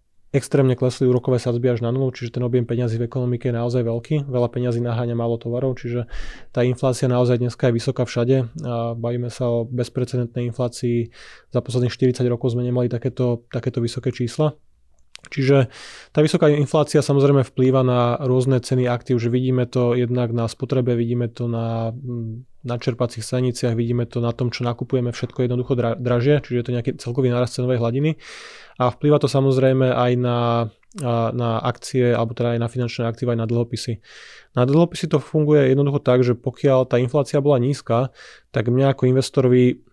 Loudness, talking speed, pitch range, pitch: -21 LUFS, 175 wpm, 120-130 Hz, 125 Hz